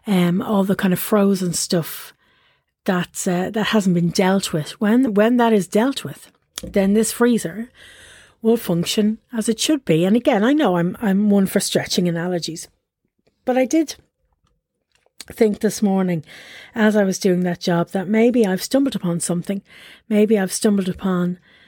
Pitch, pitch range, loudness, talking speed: 200 Hz, 180-225 Hz, -19 LUFS, 170 wpm